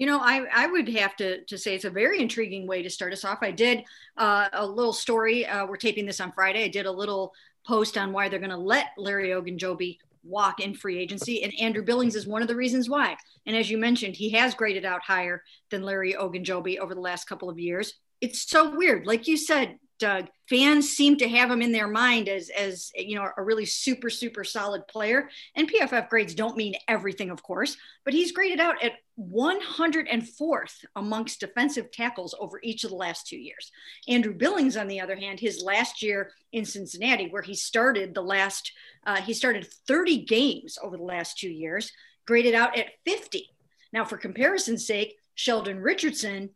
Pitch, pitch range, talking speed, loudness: 220 Hz, 195-245 Hz, 205 wpm, -26 LUFS